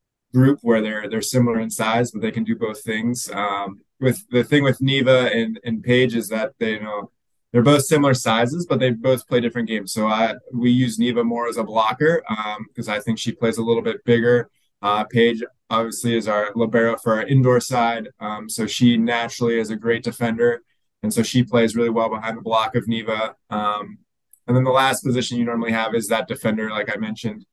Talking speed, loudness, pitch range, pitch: 220 wpm, -20 LUFS, 110-120 Hz, 115 Hz